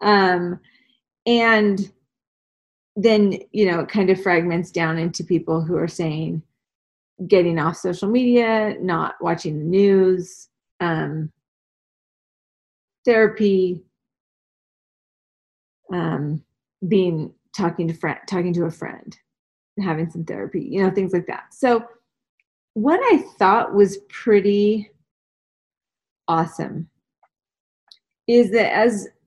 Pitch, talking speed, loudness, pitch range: 180 Hz, 105 wpm, -20 LUFS, 165-210 Hz